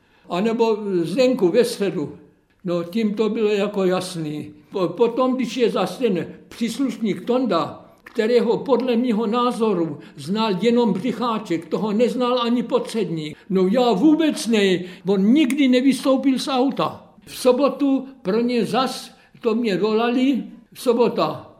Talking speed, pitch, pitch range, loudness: 135 wpm, 230 Hz, 190-245 Hz, -20 LUFS